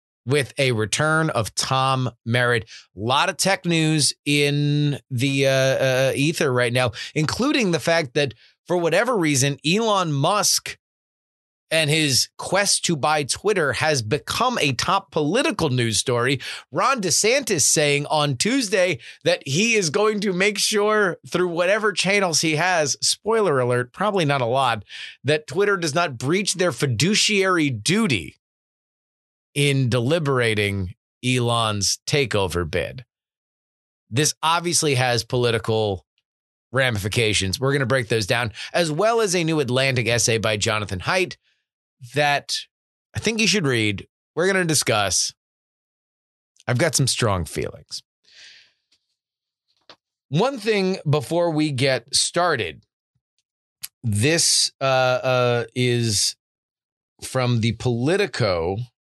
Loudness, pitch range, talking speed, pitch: -20 LUFS, 120-170 Hz, 125 wpm, 140 Hz